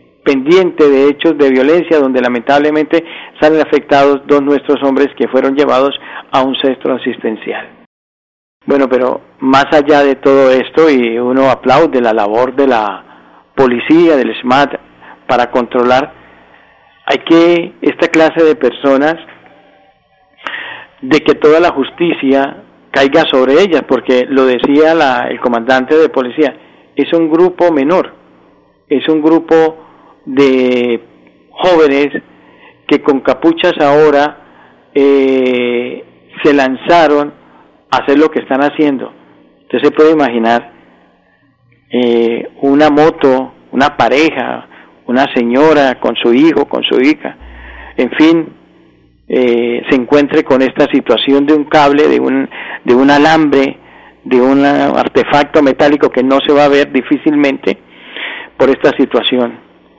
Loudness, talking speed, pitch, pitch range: -10 LUFS, 130 wpm, 140 Hz, 130-155 Hz